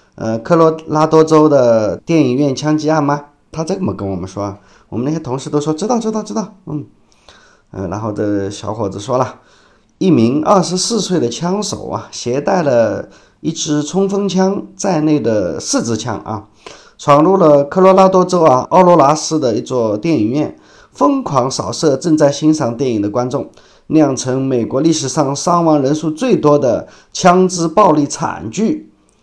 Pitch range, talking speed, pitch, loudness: 130-175 Hz, 255 characters per minute, 150 Hz, -14 LUFS